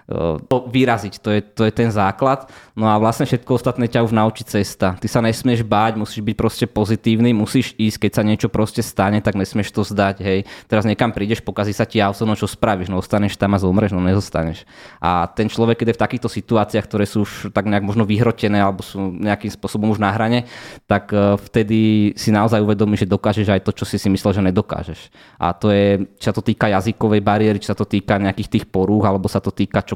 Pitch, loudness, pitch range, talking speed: 105 Hz, -18 LUFS, 100-115 Hz, 225 wpm